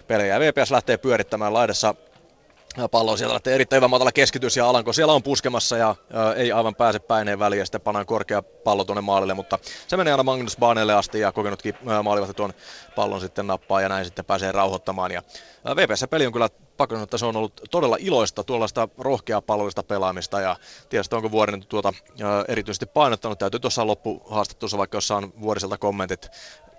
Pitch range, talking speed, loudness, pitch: 100-120 Hz, 180 wpm, -22 LUFS, 105 Hz